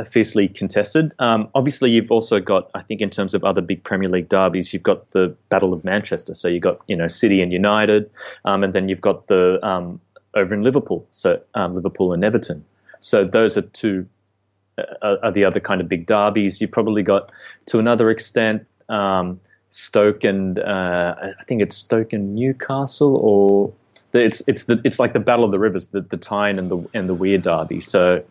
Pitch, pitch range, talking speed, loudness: 100 Hz, 95-110 Hz, 200 wpm, -19 LUFS